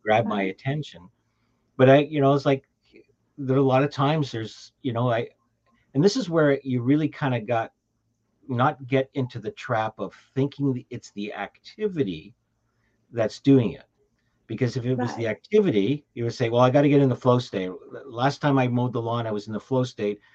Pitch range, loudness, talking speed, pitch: 115-135 Hz, -24 LUFS, 210 wpm, 125 Hz